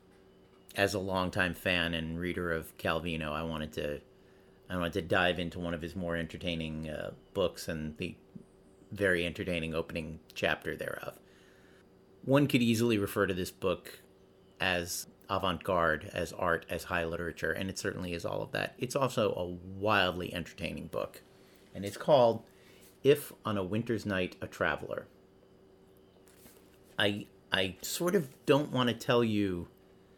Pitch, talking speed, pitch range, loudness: 95 Hz, 150 wpm, 85-100 Hz, -33 LUFS